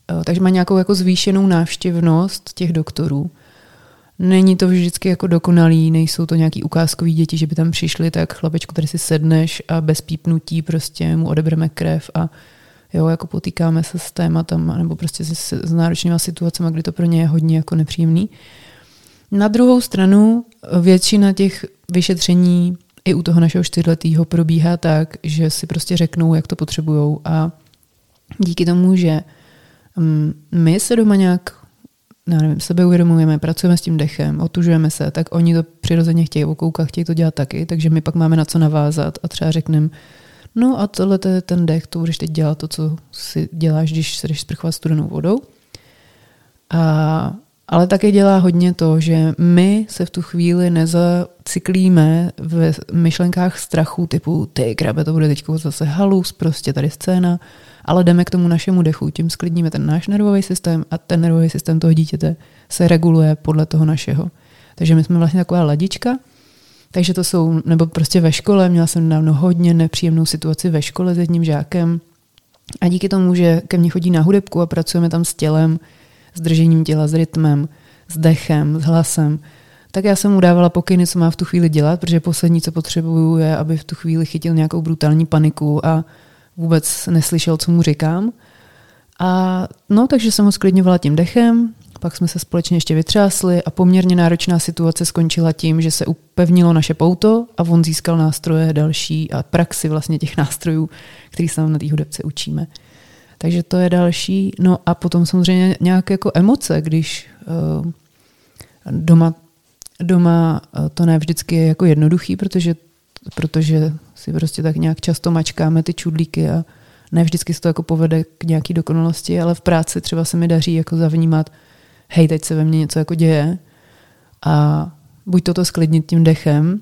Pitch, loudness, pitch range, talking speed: 165 Hz, -16 LUFS, 160-175 Hz, 175 wpm